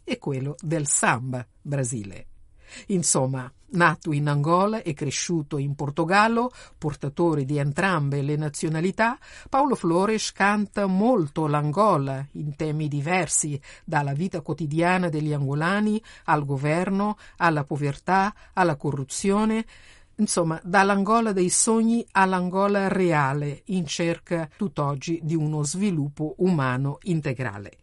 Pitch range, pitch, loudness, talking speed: 145-195 Hz, 165 Hz, -24 LUFS, 110 wpm